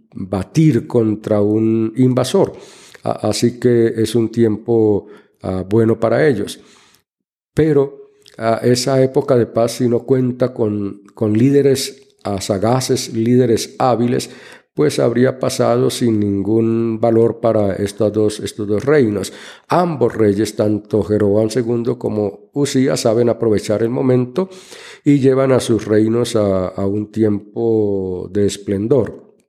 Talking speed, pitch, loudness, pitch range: 120 wpm, 115 Hz, -16 LUFS, 105-125 Hz